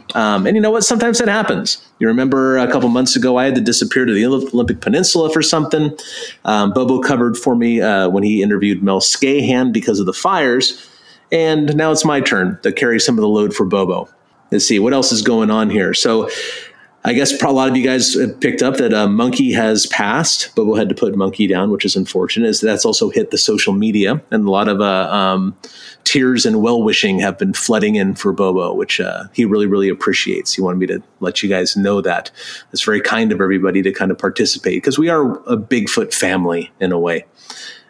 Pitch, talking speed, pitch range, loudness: 120 Hz, 220 wpm, 100-155 Hz, -15 LUFS